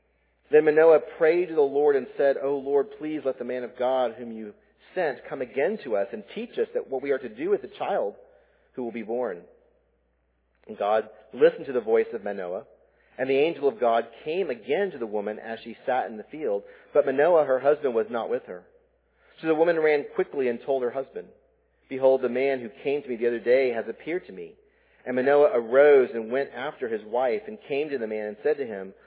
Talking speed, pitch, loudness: 230 wpm, 155 Hz, -25 LUFS